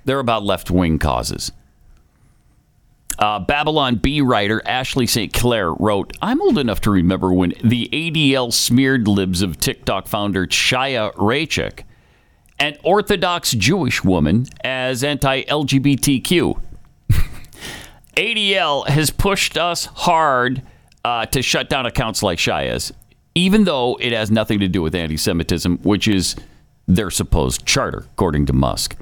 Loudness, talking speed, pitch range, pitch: -17 LUFS, 135 wpm, 95-140 Hz, 120 Hz